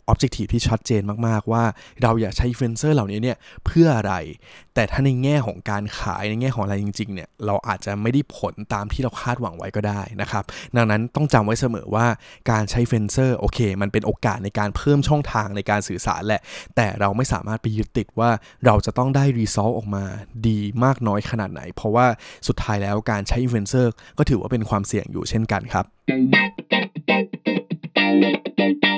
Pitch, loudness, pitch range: 110 Hz, -22 LUFS, 100-120 Hz